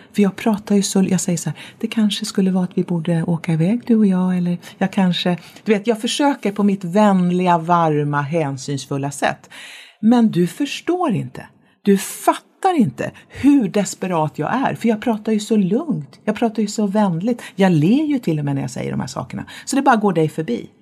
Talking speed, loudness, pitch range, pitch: 215 wpm, -19 LUFS, 175-225 Hz, 200 Hz